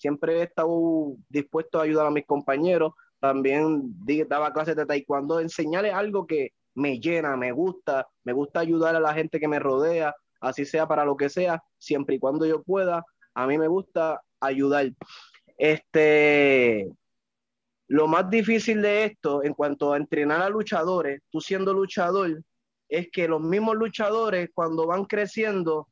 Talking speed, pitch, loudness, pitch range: 160 wpm, 160 Hz, -25 LUFS, 145-180 Hz